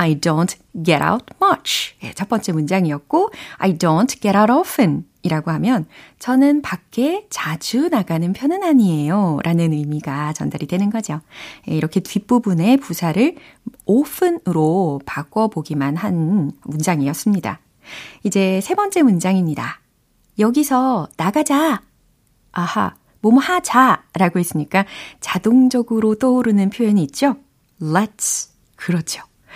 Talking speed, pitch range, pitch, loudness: 305 characters per minute, 165-255 Hz, 200 Hz, -18 LUFS